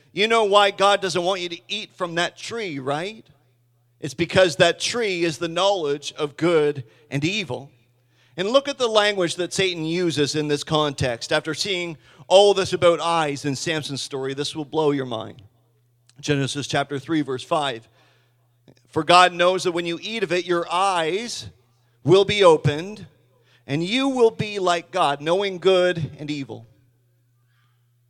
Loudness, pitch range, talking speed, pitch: -21 LUFS, 130-180 Hz, 165 wpm, 155 Hz